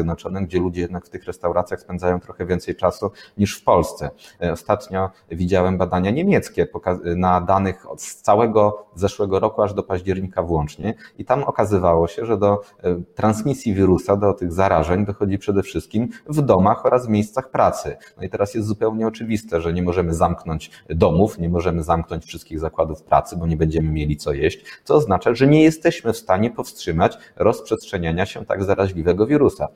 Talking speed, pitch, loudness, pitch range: 165 wpm, 95 Hz, -20 LUFS, 85-105 Hz